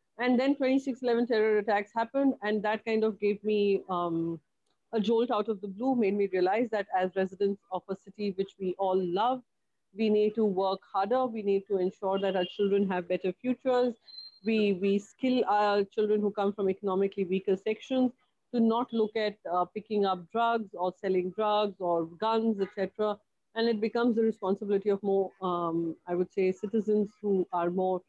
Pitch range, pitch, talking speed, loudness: 190-225 Hz, 205 Hz, 190 wpm, -29 LUFS